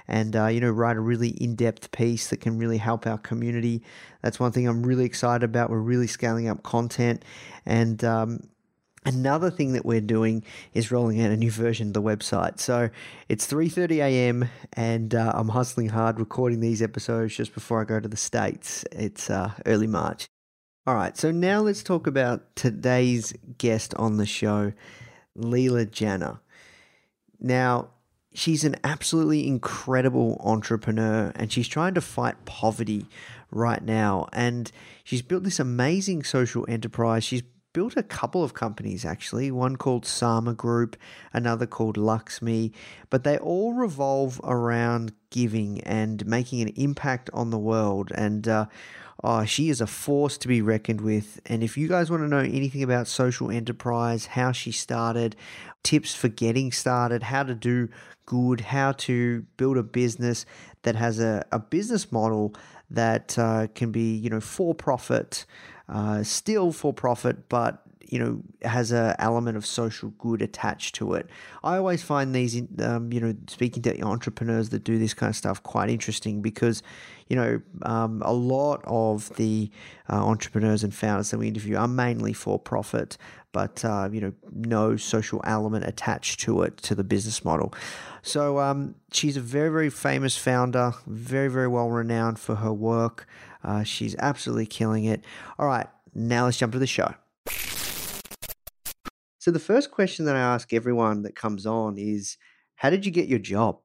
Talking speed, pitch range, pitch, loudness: 170 wpm, 110-125 Hz, 115 Hz, -26 LUFS